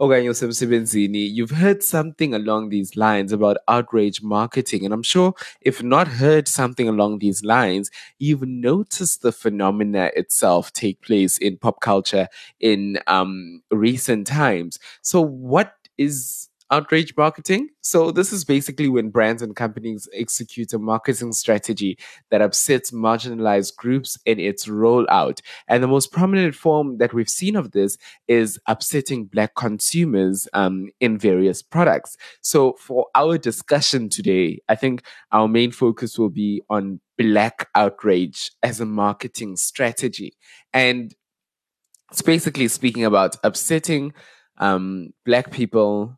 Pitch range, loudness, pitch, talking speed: 105-135 Hz, -20 LUFS, 115 Hz, 135 wpm